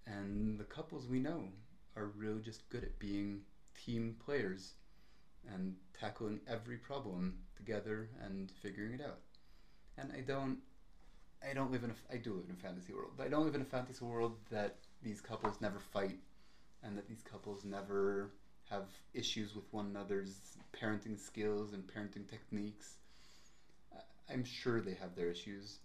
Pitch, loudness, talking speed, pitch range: 105 Hz, -44 LUFS, 165 wpm, 100-120 Hz